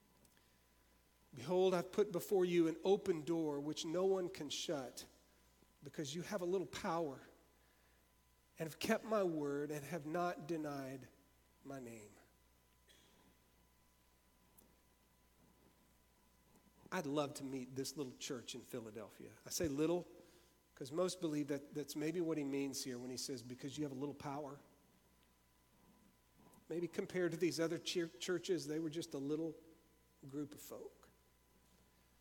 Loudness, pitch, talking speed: -42 LUFS, 145 Hz, 140 wpm